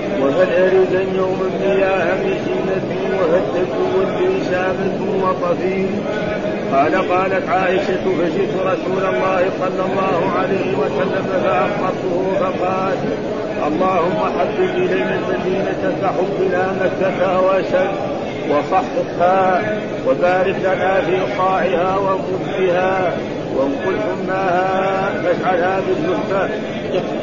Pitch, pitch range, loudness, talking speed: 185 Hz, 180-190 Hz, -17 LUFS, 85 wpm